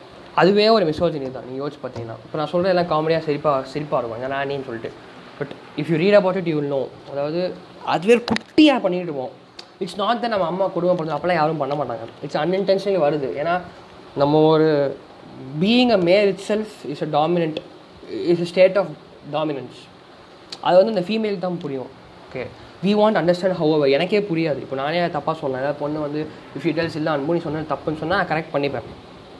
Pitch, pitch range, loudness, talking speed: 160 Hz, 145-185 Hz, -20 LUFS, 180 wpm